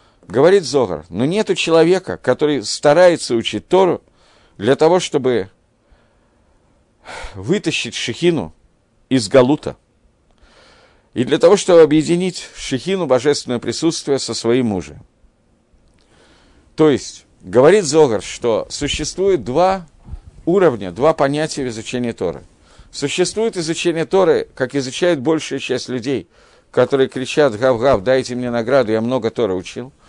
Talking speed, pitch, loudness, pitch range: 120 wpm, 140 Hz, -16 LUFS, 120-165 Hz